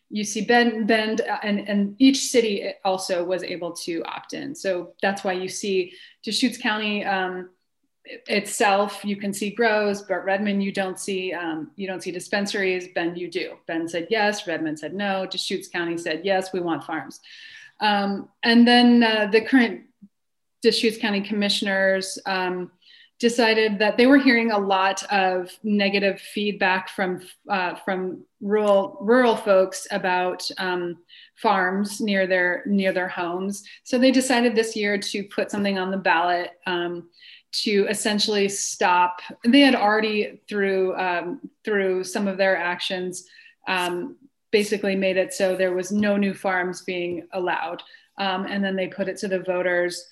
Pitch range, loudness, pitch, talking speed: 185-220 Hz, -22 LUFS, 200 Hz, 160 wpm